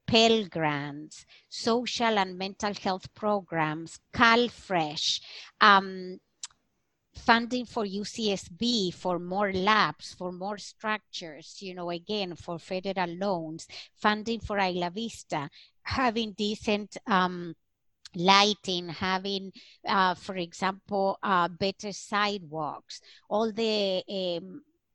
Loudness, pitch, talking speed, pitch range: -28 LUFS, 195 Hz, 100 wpm, 180-210 Hz